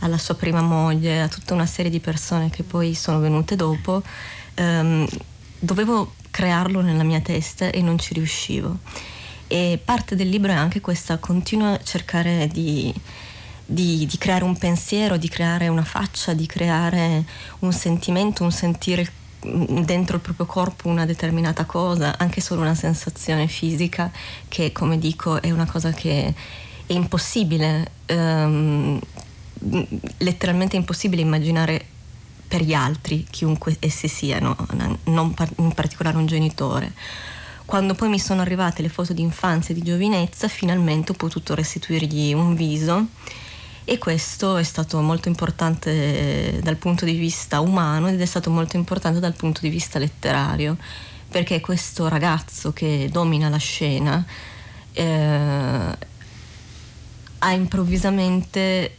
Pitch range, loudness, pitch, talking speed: 155-180 Hz, -21 LUFS, 165 Hz, 135 wpm